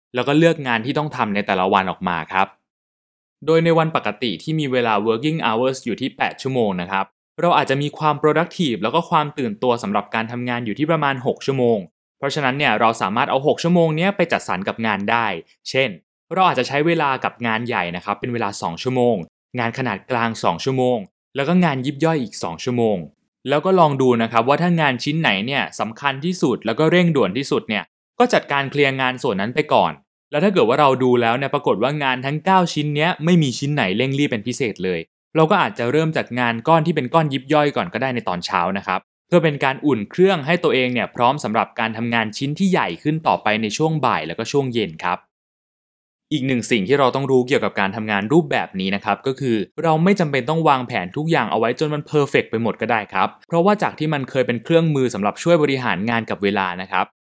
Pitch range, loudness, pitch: 115-155 Hz, -19 LUFS, 135 Hz